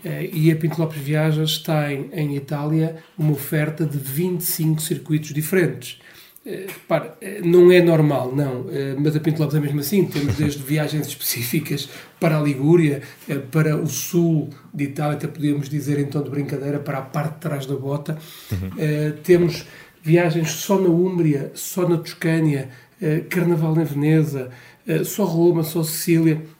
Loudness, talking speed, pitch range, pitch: -21 LUFS, 165 wpm, 145-165 Hz, 155 Hz